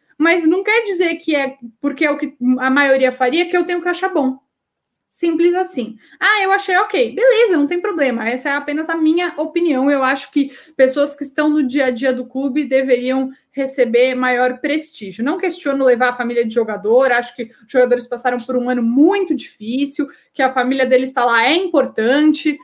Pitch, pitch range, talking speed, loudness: 280 Hz, 255-325 Hz, 200 wpm, -16 LUFS